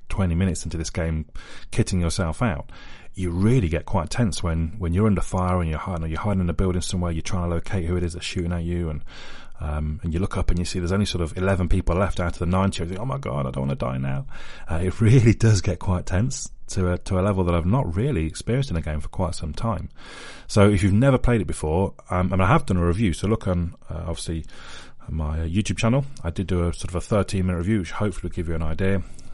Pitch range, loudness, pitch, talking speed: 85-100 Hz, -24 LUFS, 90 Hz, 275 wpm